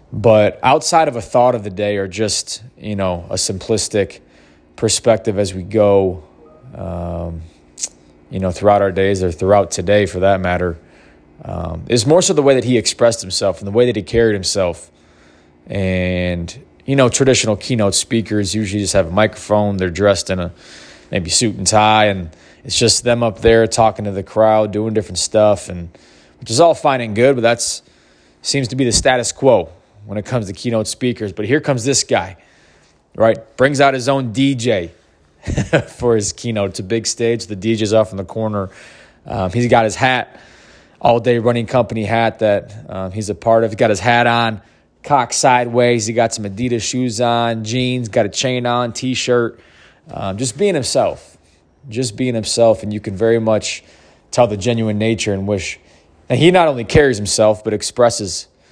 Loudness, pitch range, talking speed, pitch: -16 LUFS, 95-120 Hz, 190 wpm, 110 Hz